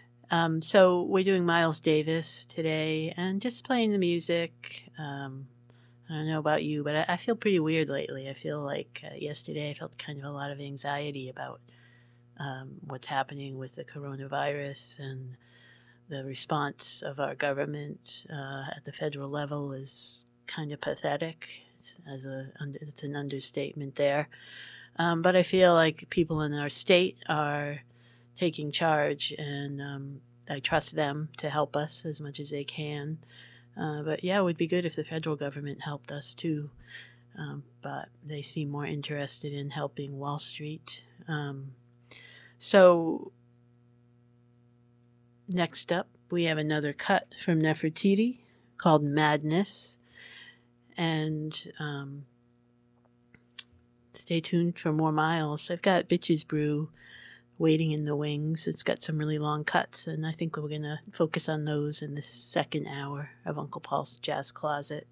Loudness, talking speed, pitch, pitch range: -30 LUFS, 155 wpm, 145 Hz, 135-160 Hz